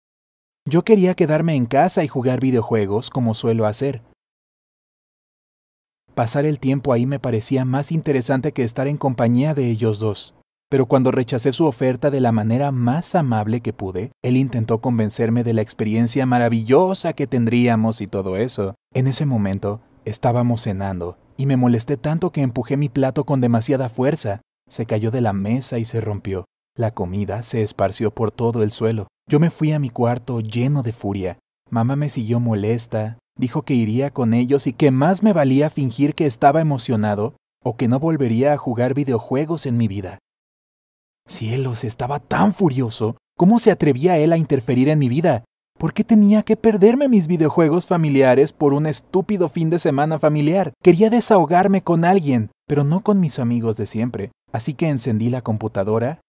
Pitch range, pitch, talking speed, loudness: 115-150 Hz, 130 Hz, 175 wpm, -19 LUFS